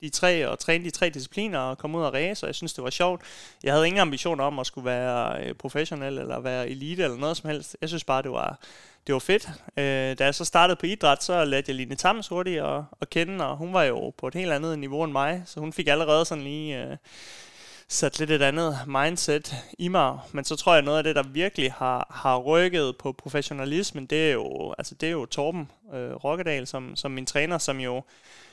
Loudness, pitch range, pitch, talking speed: -26 LUFS, 135-170 Hz, 150 Hz, 240 wpm